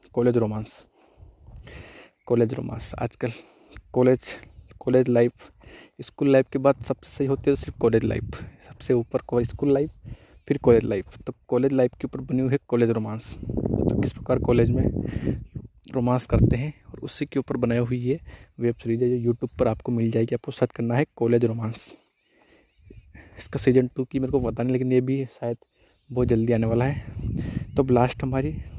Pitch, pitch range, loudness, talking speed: 125 Hz, 115-135 Hz, -24 LUFS, 180 wpm